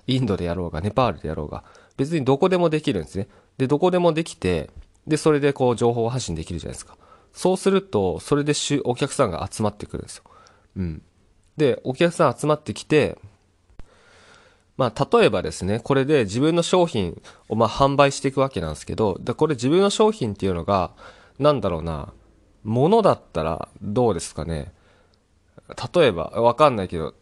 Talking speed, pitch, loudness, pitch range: 375 characters per minute, 110 Hz, -22 LUFS, 90-145 Hz